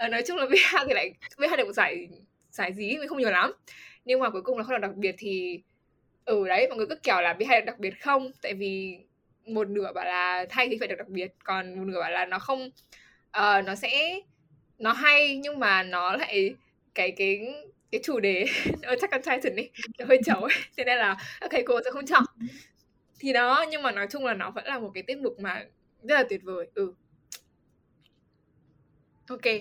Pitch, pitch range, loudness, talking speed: 225 Hz, 190-270 Hz, -26 LUFS, 230 wpm